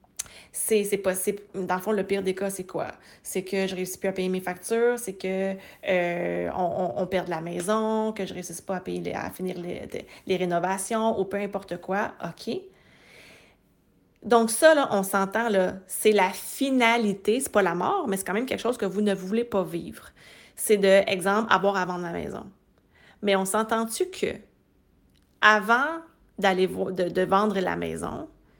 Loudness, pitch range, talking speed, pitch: -26 LUFS, 185-215 Hz, 205 wpm, 195 Hz